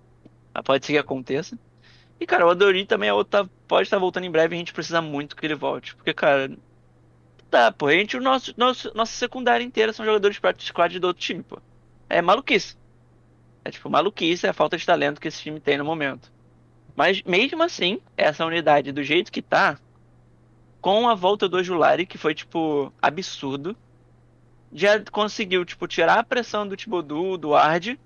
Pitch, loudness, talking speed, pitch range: 175 Hz, -22 LUFS, 190 wpm, 145-210 Hz